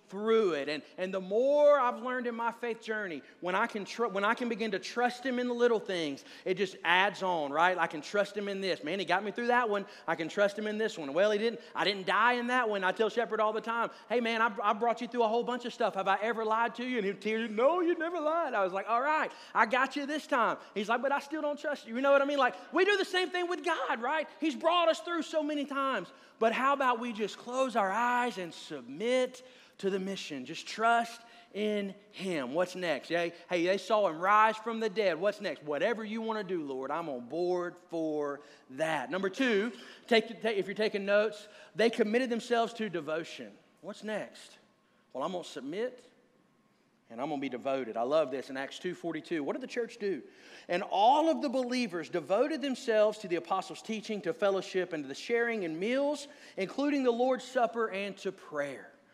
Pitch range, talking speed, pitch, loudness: 190-250 Hz, 235 wpm, 225 Hz, -31 LUFS